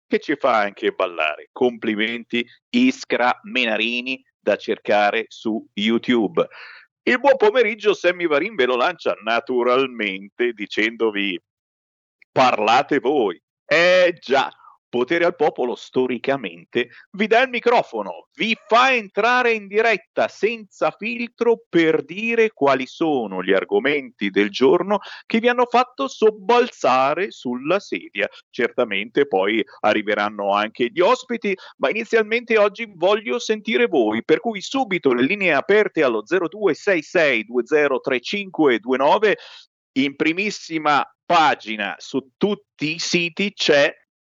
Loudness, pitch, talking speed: -20 LUFS, 175 Hz, 115 wpm